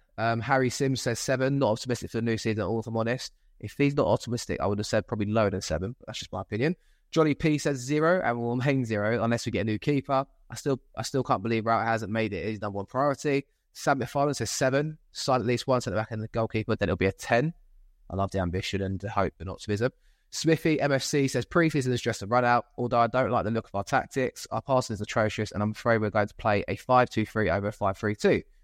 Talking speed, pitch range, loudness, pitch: 255 wpm, 105-135 Hz, -27 LUFS, 115 Hz